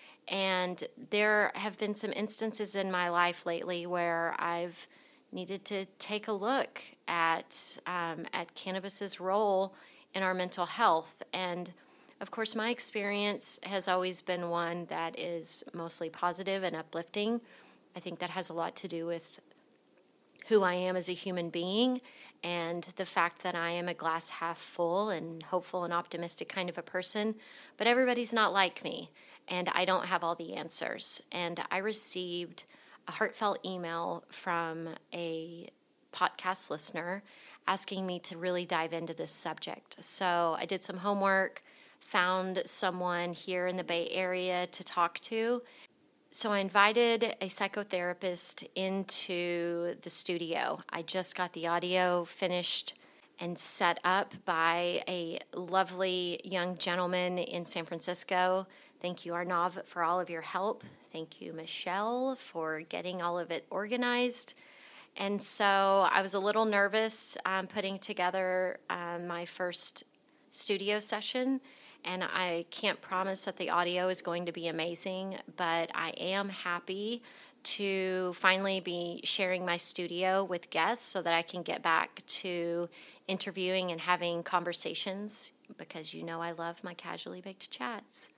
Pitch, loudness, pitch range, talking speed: 180 Hz, -33 LUFS, 175-195 Hz, 150 wpm